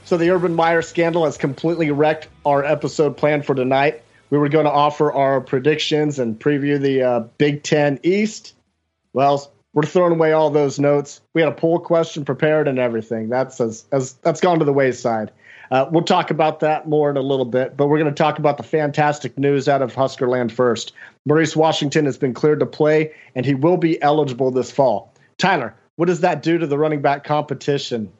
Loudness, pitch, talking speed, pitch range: -18 LUFS, 145 Hz, 205 wpm, 135-155 Hz